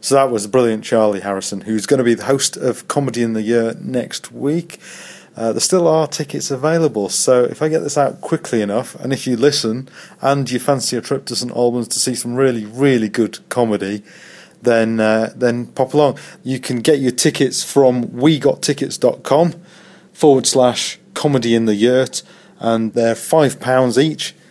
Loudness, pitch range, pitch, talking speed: -16 LUFS, 115-145 Hz, 130 Hz, 185 wpm